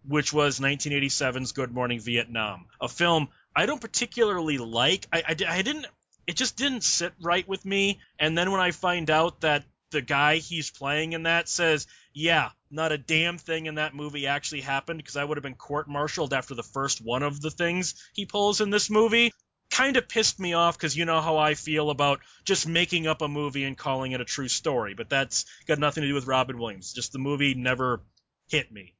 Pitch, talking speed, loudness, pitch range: 150 Hz, 215 wpm, -26 LUFS, 135-170 Hz